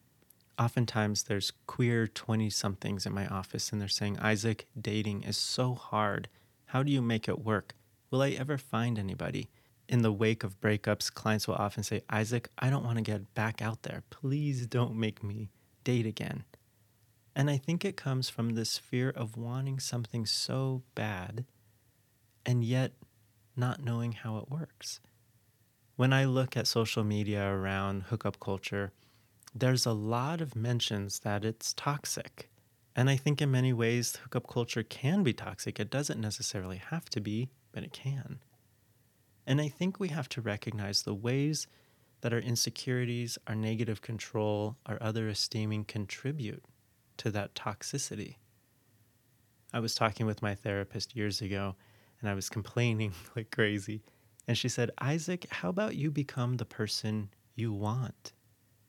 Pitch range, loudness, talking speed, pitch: 105-125 Hz, -33 LUFS, 160 wpm, 115 Hz